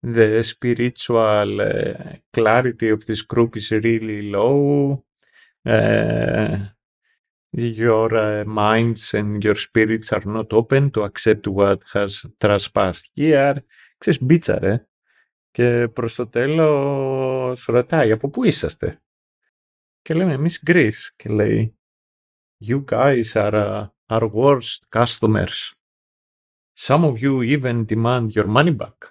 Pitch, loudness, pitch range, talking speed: 115 Hz, -19 LUFS, 105-135 Hz, 120 wpm